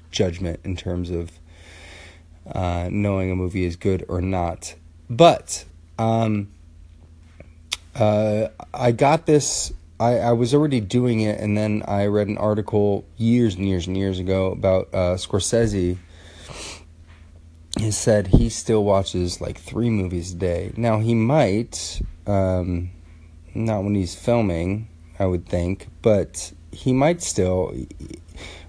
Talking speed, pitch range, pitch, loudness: 135 wpm, 85-105 Hz, 95 Hz, -22 LUFS